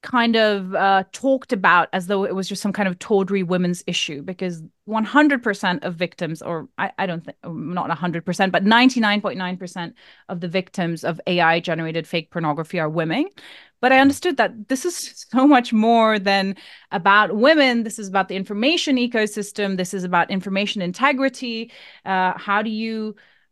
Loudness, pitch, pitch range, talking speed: -20 LUFS, 200 Hz, 180-230 Hz, 170 wpm